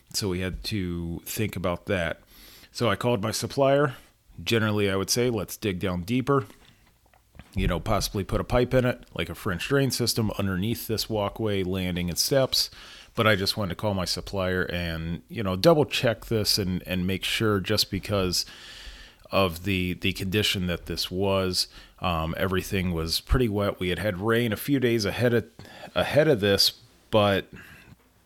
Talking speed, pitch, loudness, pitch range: 180 wpm, 100 Hz, -26 LUFS, 90-115 Hz